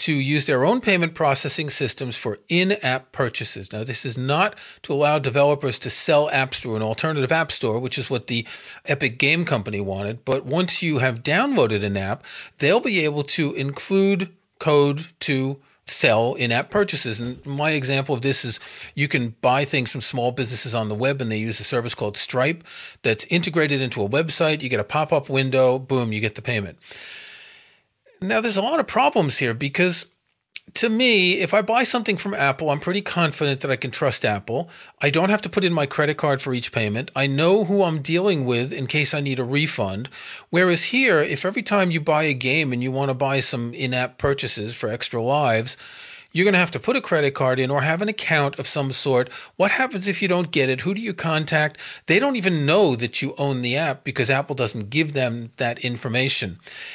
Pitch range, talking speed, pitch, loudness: 130-170 Hz, 215 wpm, 140 Hz, -21 LUFS